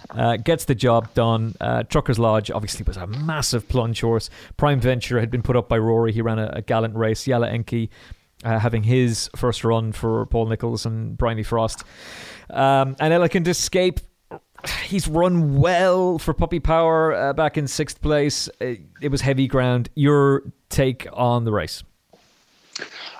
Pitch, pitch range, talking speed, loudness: 125 Hz, 115-145 Hz, 170 wpm, -21 LUFS